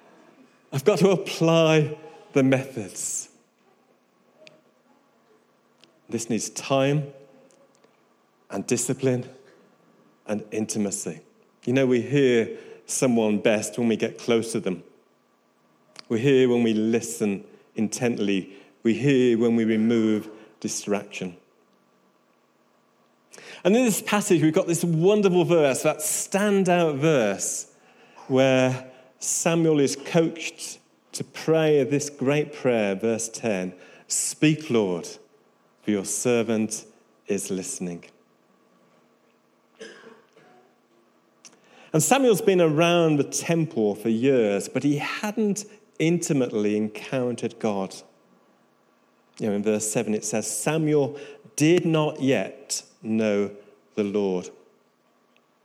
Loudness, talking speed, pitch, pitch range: -23 LUFS, 100 wpm, 130 Hz, 110-160 Hz